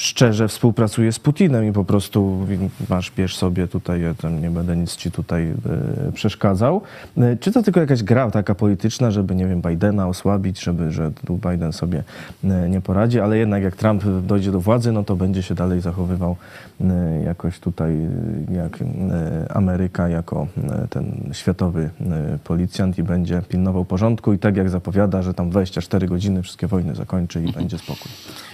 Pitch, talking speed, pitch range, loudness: 95 Hz, 160 wpm, 90-105 Hz, -20 LUFS